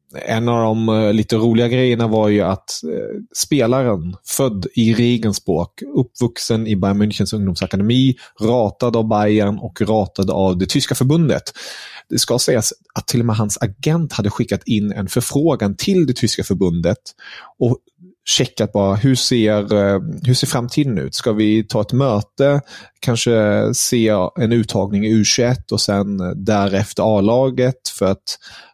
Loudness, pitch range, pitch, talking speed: -17 LUFS, 105-125 Hz, 110 Hz, 150 wpm